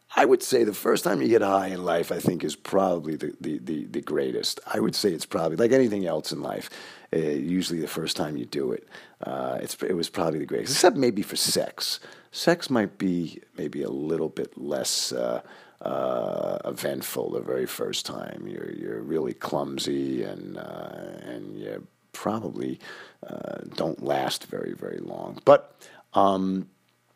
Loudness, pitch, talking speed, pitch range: -27 LUFS, 95 Hz, 180 wpm, 80-100 Hz